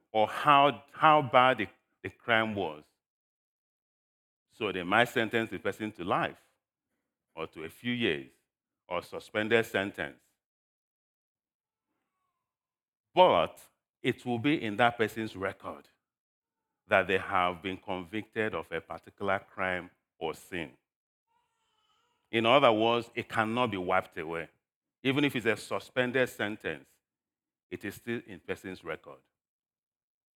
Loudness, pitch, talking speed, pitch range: -30 LUFS, 110 Hz, 125 wpm, 95-125 Hz